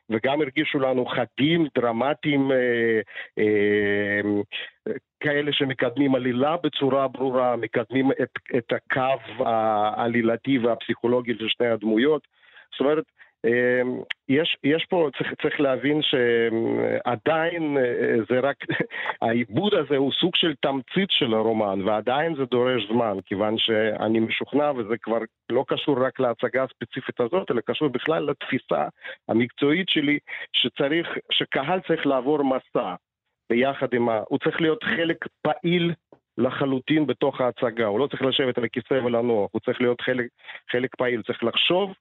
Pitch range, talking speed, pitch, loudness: 115-145 Hz, 135 wpm, 130 Hz, -24 LUFS